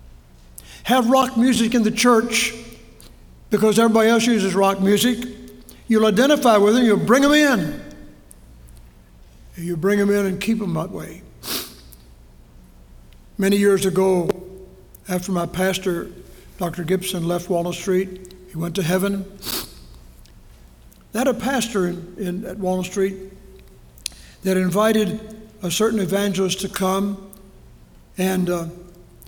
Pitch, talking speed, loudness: 185 Hz, 125 wpm, -20 LUFS